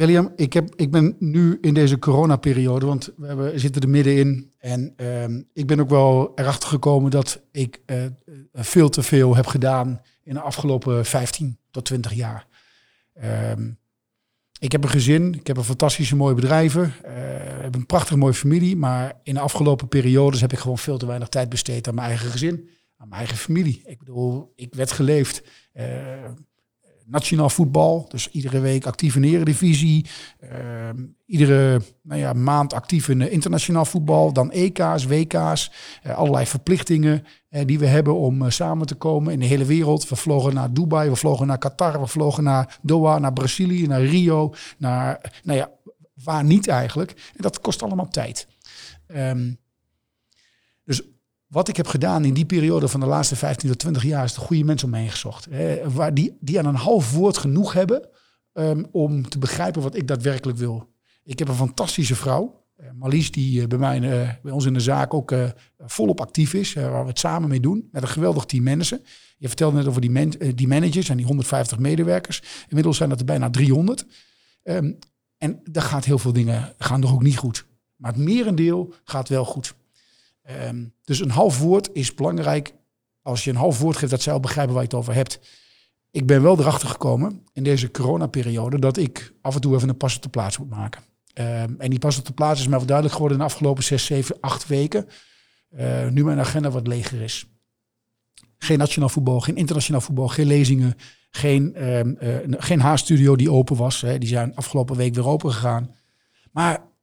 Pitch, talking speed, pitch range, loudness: 135 Hz, 200 wpm, 125-155 Hz, -21 LUFS